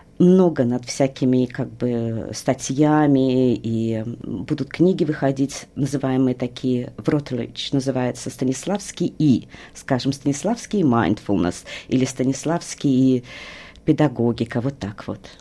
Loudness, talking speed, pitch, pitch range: -21 LUFS, 105 wpm, 130 Hz, 125-145 Hz